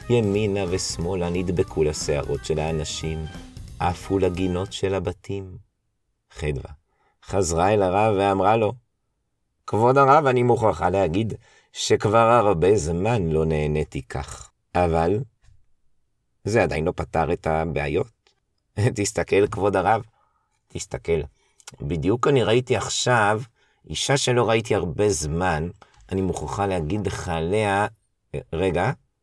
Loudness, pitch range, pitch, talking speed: -22 LUFS, 85-110 Hz, 100 Hz, 110 wpm